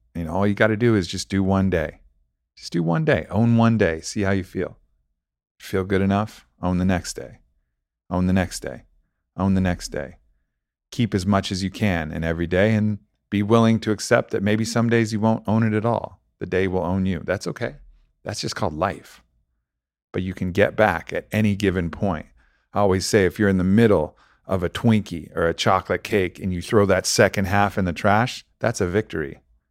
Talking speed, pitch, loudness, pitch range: 220 wpm, 95 Hz, -22 LUFS, 85-105 Hz